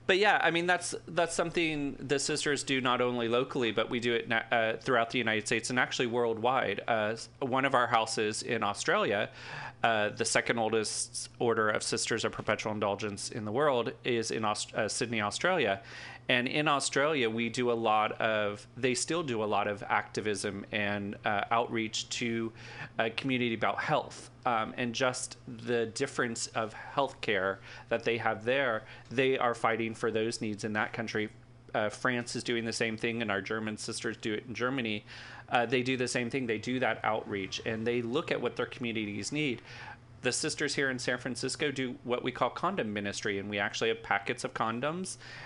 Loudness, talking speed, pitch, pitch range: -31 LUFS, 195 wpm, 120 Hz, 110-125 Hz